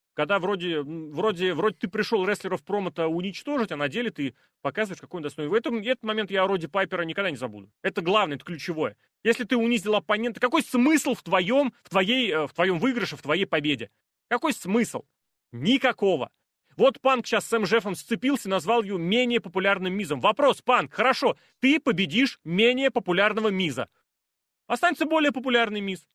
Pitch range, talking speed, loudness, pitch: 175-240 Hz, 170 wpm, -25 LUFS, 205 Hz